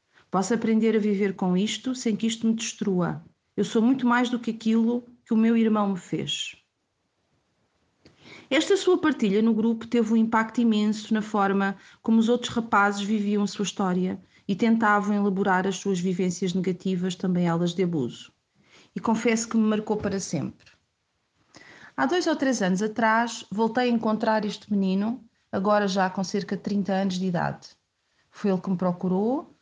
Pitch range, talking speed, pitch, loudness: 195-225 Hz, 175 wpm, 210 Hz, -25 LUFS